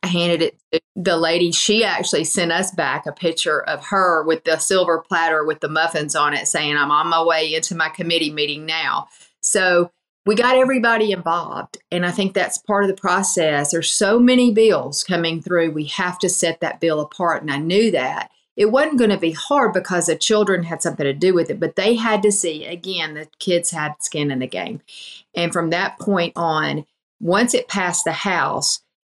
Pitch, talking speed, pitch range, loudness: 170 Hz, 210 wpm, 160-195 Hz, -18 LUFS